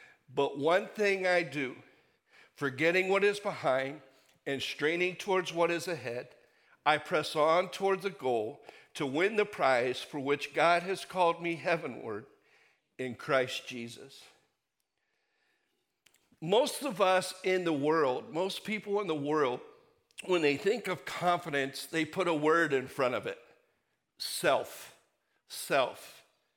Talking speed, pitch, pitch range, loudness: 140 wpm, 175 Hz, 145-200 Hz, -31 LUFS